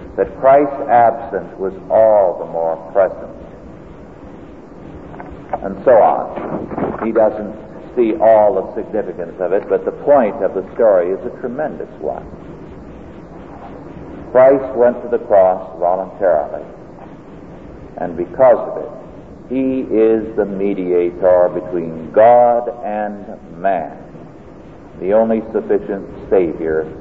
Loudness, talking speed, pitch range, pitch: -15 LUFS, 115 wpm, 90-120 Hz, 110 Hz